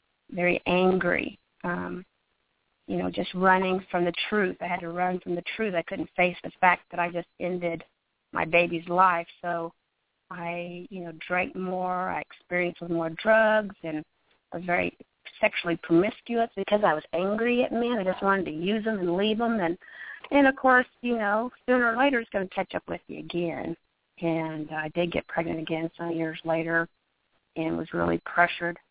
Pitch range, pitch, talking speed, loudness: 170-200 Hz, 175 Hz, 190 wpm, -27 LUFS